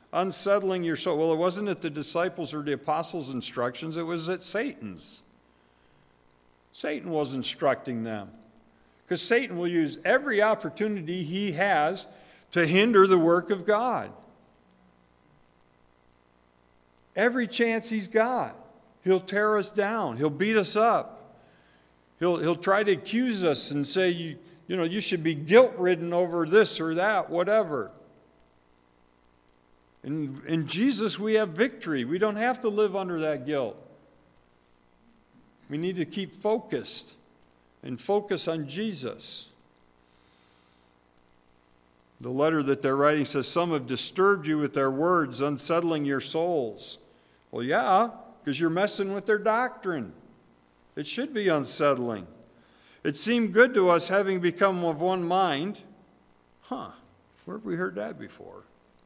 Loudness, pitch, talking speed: -26 LUFS, 160 Hz, 135 wpm